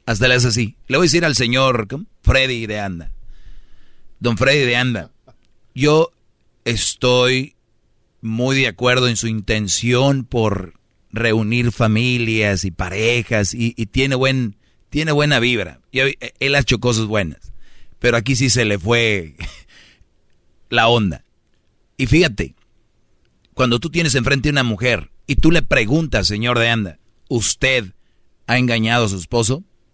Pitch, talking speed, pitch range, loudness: 120 Hz, 145 wpm, 110-130 Hz, -17 LUFS